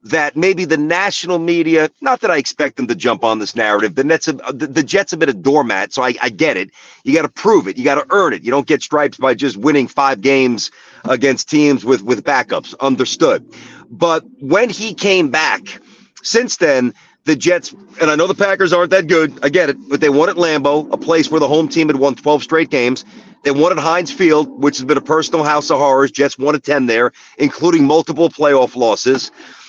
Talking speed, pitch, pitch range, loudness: 230 wpm, 150 Hz, 135-170 Hz, -14 LUFS